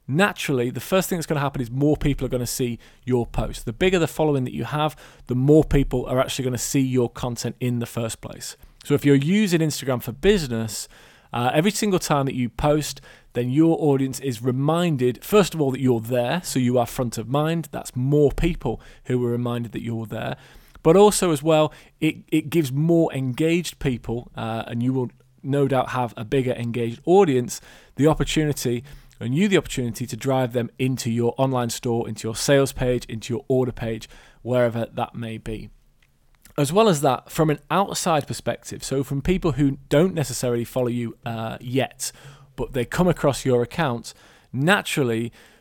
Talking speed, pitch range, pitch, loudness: 190 wpm, 120-150 Hz, 130 Hz, -22 LUFS